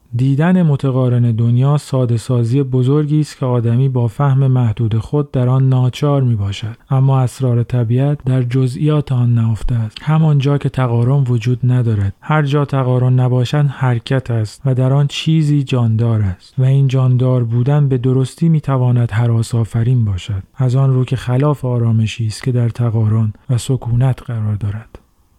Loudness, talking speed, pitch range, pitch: -15 LUFS, 160 wpm, 120-135 Hz, 125 Hz